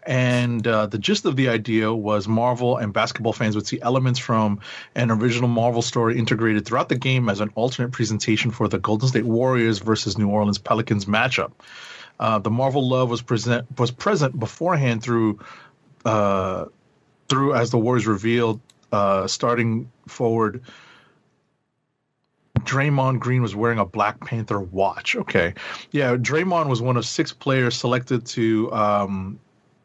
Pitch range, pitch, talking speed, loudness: 110-125 Hz, 115 Hz, 155 wpm, -22 LUFS